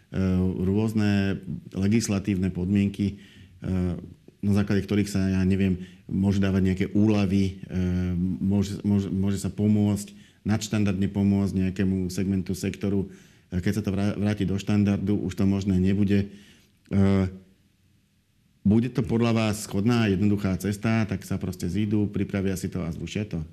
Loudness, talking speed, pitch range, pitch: -25 LUFS, 130 wpm, 95-100 Hz, 100 Hz